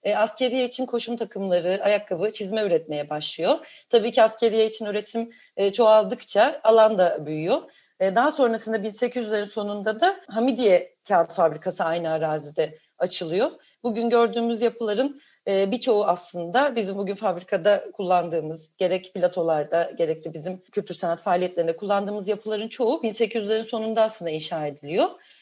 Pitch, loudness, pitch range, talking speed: 210 Hz, -24 LUFS, 180-230 Hz, 130 wpm